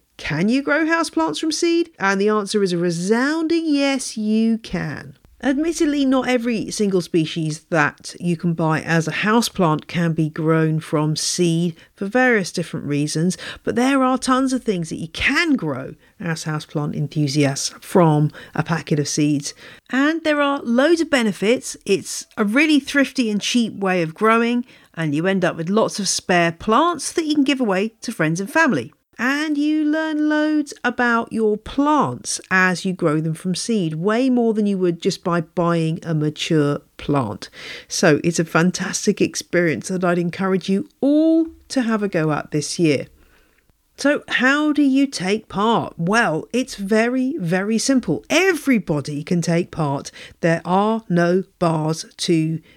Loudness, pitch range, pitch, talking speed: -19 LUFS, 165-260 Hz, 200 Hz, 170 wpm